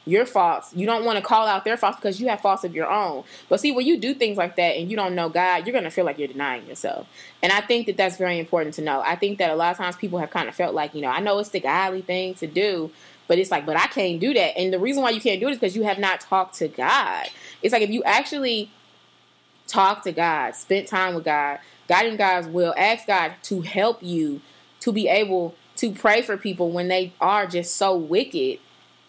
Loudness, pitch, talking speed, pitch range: -22 LUFS, 190 Hz, 265 wpm, 175-215 Hz